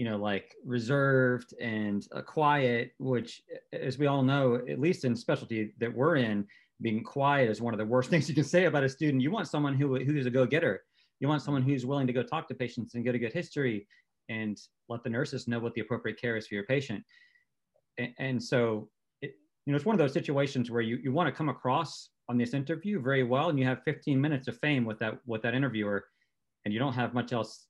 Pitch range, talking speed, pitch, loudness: 115-145 Hz, 235 wpm, 130 Hz, -30 LUFS